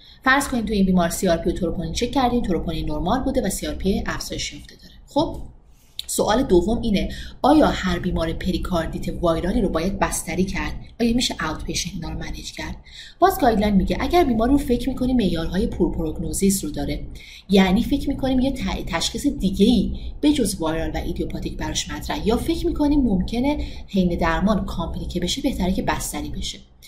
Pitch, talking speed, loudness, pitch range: 185 Hz, 180 wpm, -22 LUFS, 165-240 Hz